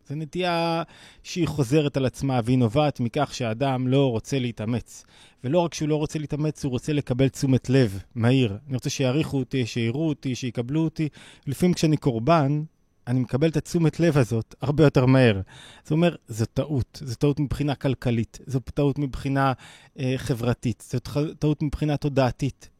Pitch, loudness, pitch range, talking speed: 135 Hz, -24 LUFS, 125-150 Hz, 165 wpm